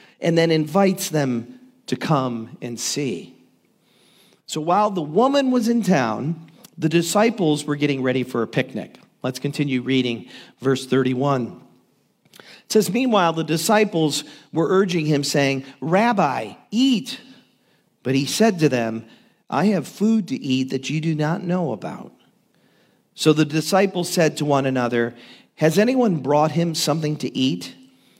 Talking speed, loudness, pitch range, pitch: 145 wpm, -21 LUFS, 135-205 Hz, 160 Hz